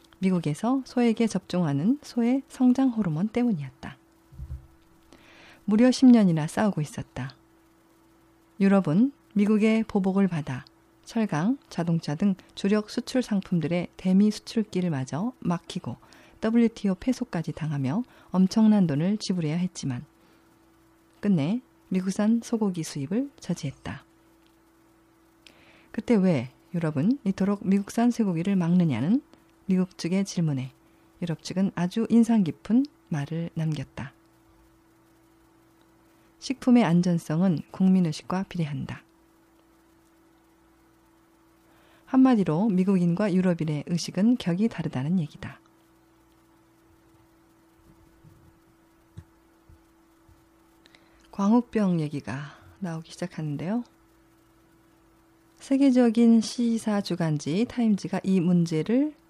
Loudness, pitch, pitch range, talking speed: -25 LUFS, 190 Hz, 165-230 Hz, 225 characters per minute